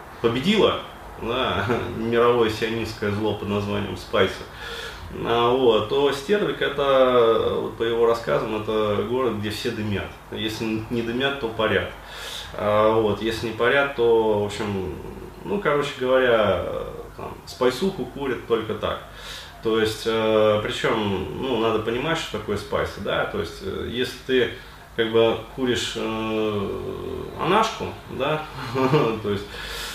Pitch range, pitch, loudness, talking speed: 105-125 Hz, 115 Hz, -23 LUFS, 130 wpm